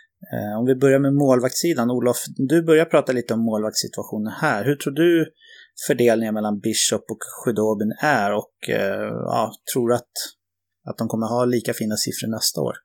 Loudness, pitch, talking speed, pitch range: -21 LUFS, 120 Hz, 170 wpm, 110-145 Hz